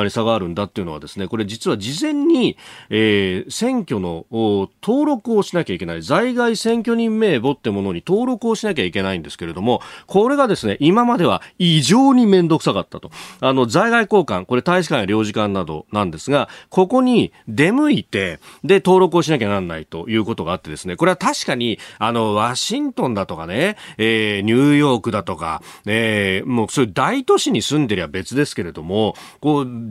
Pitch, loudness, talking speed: 130 Hz, -18 LUFS, 395 characters per minute